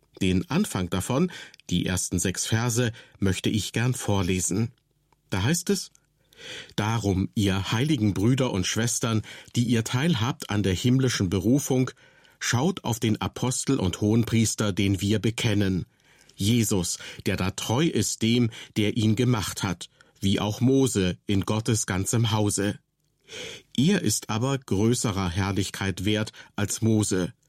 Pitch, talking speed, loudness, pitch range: 110 Hz, 135 wpm, -25 LUFS, 100-125 Hz